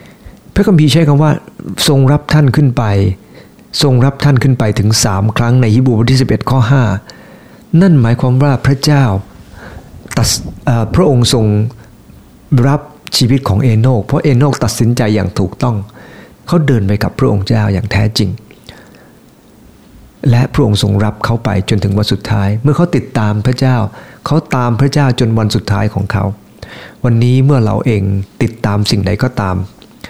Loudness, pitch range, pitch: -12 LUFS, 105-135 Hz, 120 Hz